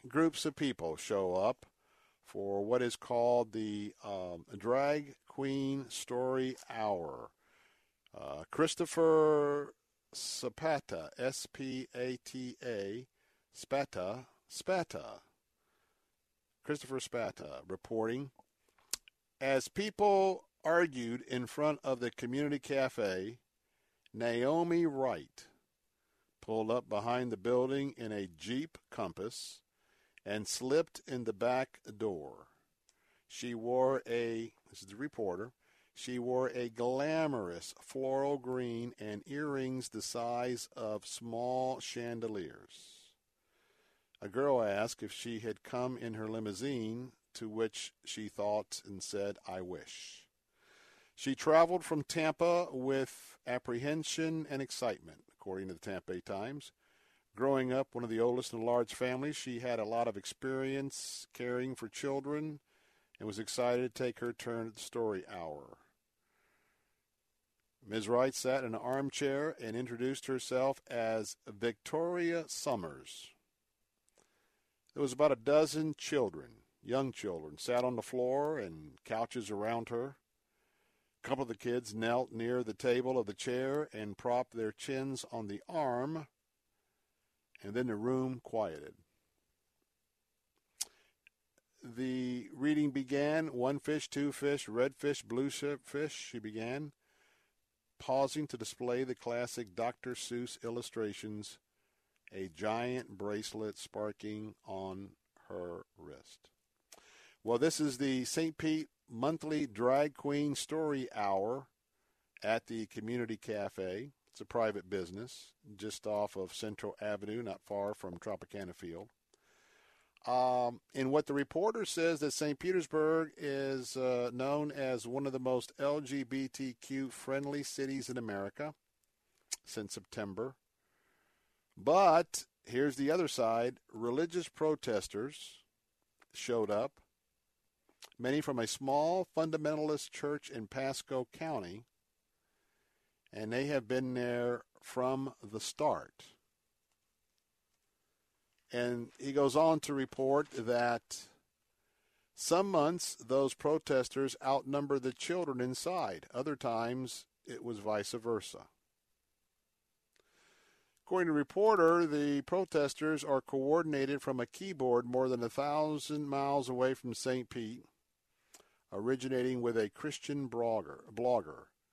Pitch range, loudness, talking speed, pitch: 115-140 Hz, -36 LUFS, 115 wpm, 125 Hz